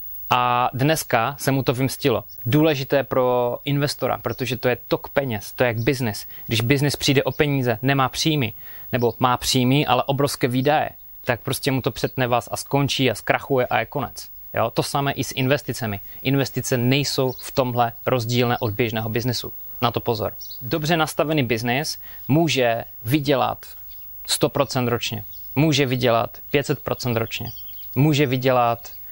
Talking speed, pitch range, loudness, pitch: 150 wpm, 120-140 Hz, -22 LUFS, 130 Hz